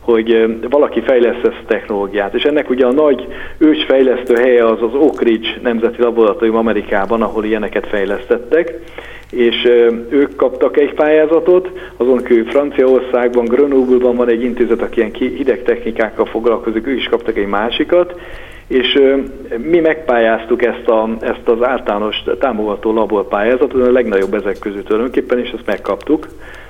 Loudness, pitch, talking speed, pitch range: -14 LUFS, 125 Hz, 140 wpm, 115-145 Hz